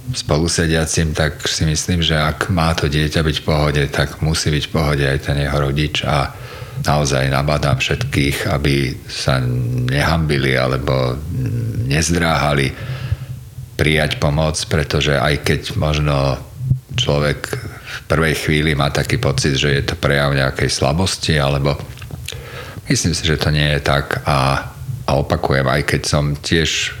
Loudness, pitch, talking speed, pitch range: -17 LUFS, 75 Hz, 140 wpm, 70-85 Hz